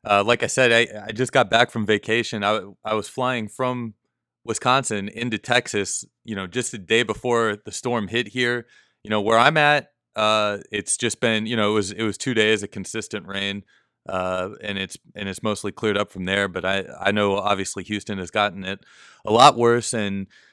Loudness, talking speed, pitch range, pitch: -22 LUFS, 210 wpm, 100-120 Hz, 105 Hz